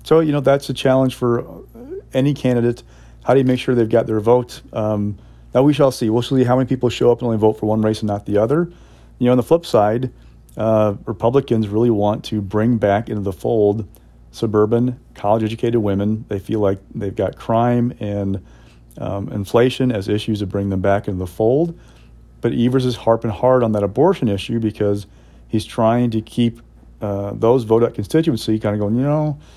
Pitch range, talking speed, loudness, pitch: 100-125 Hz, 205 wpm, -18 LUFS, 110 Hz